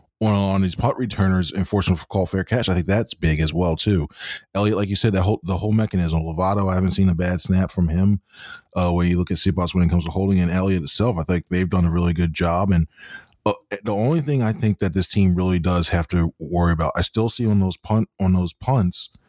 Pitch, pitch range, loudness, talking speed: 95 Hz, 90-100 Hz, -21 LUFS, 250 wpm